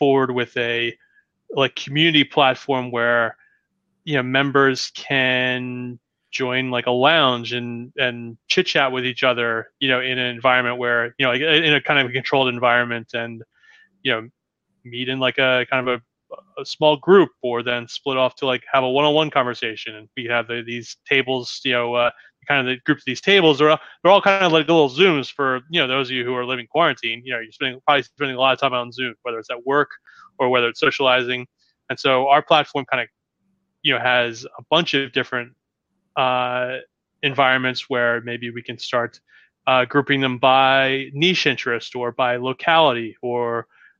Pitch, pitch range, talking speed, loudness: 130 Hz, 120-140 Hz, 200 wpm, -19 LUFS